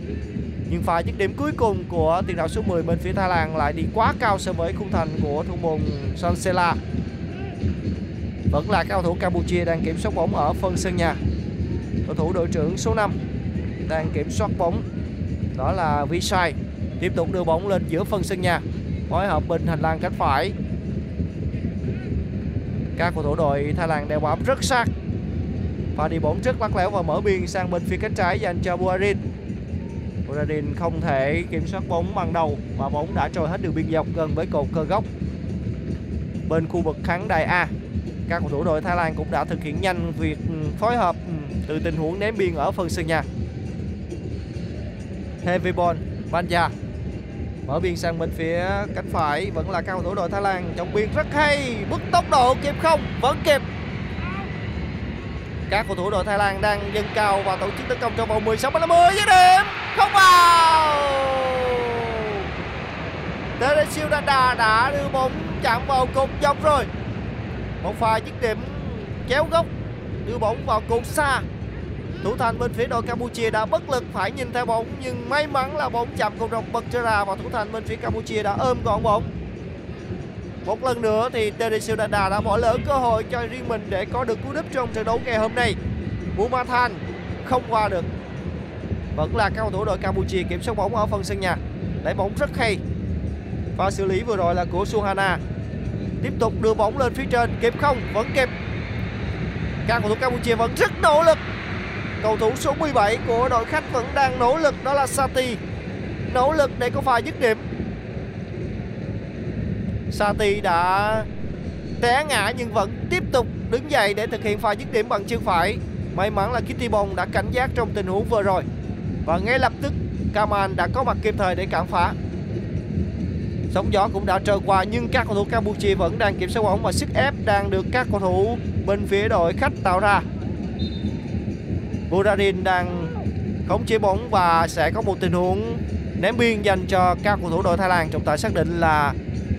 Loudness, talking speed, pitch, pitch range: -22 LUFS, 195 wpm, 215 Hz, 185-265 Hz